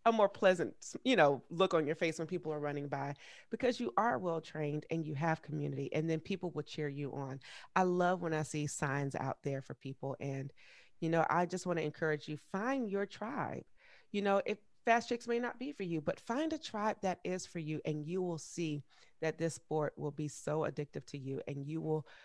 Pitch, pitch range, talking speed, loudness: 160 Hz, 150-185 Hz, 230 wpm, -37 LUFS